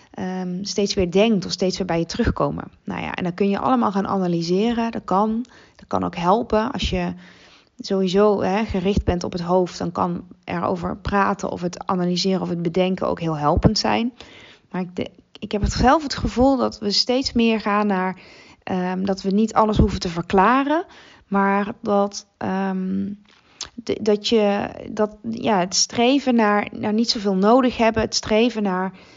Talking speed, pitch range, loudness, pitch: 185 wpm, 185-225 Hz, -21 LUFS, 200 Hz